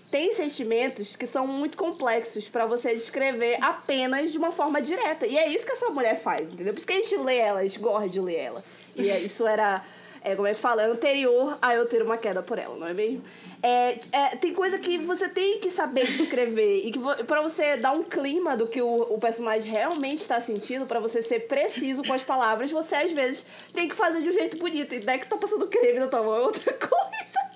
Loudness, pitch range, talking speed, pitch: -26 LUFS, 230-335 Hz, 235 wpm, 265 Hz